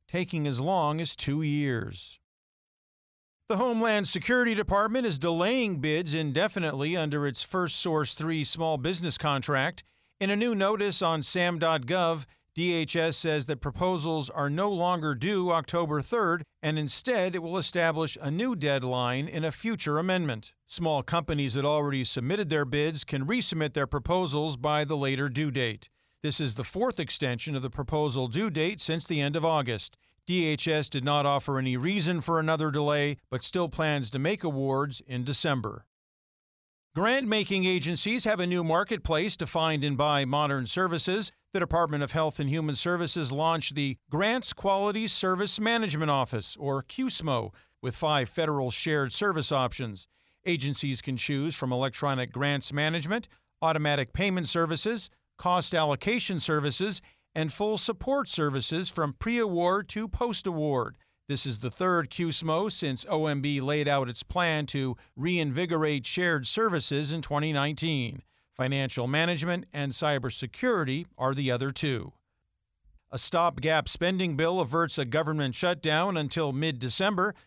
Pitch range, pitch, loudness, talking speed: 140-175 Hz, 155 Hz, -28 LUFS, 150 wpm